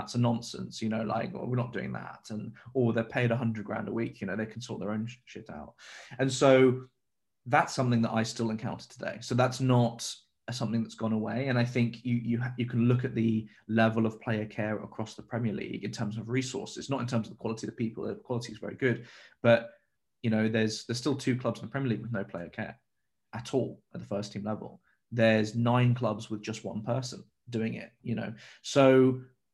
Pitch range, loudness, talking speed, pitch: 110-125 Hz, -30 LUFS, 240 wpm, 115 Hz